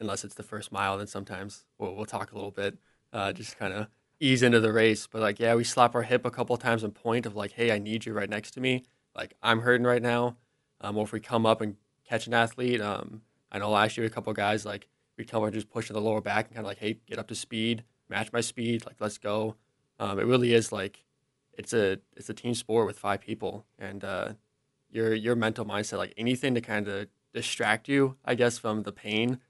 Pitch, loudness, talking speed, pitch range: 110 Hz, -29 LUFS, 250 wpm, 105-120 Hz